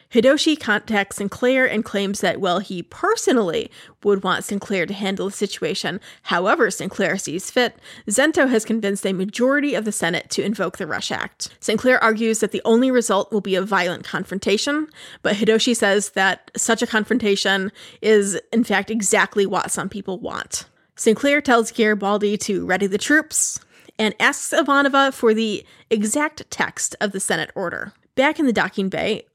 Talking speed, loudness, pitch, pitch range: 170 wpm, -20 LUFS, 215 Hz, 195-240 Hz